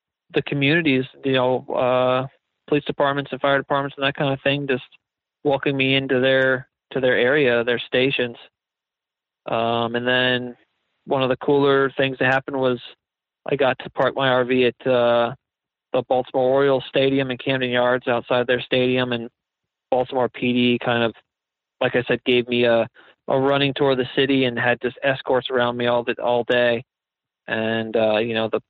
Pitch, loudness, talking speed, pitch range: 130 Hz, -21 LUFS, 185 wpm, 120-135 Hz